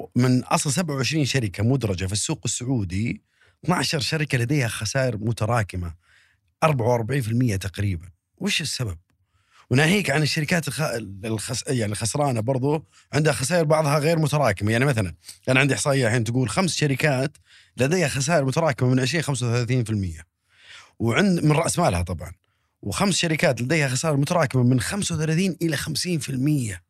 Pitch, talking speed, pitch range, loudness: 130 Hz, 130 wpm, 110-155 Hz, -23 LUFS